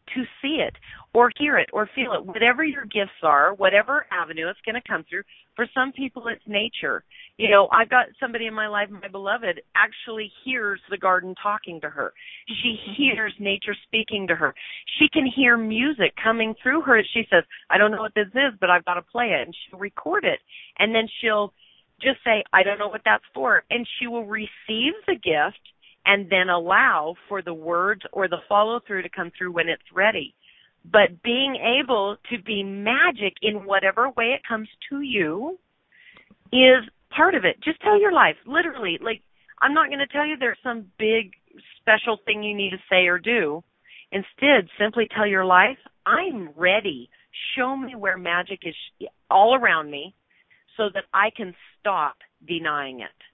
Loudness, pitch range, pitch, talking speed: -21 LUFS, 195-255 Hz, 220 Hz, 190 wpm